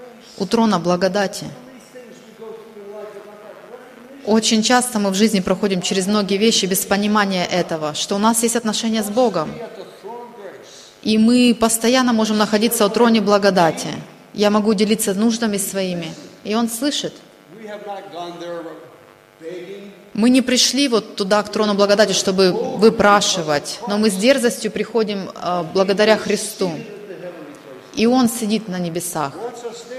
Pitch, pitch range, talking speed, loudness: 210 Hz, 195-230 Hz, 120 wpm, -17 LUFS